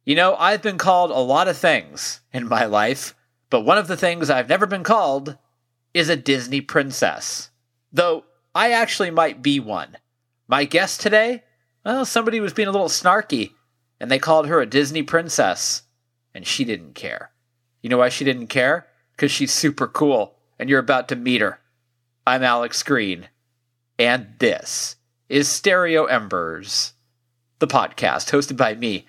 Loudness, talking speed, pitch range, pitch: -19 LUFS, 165 wpm, 120-175 Hz, 135 Hz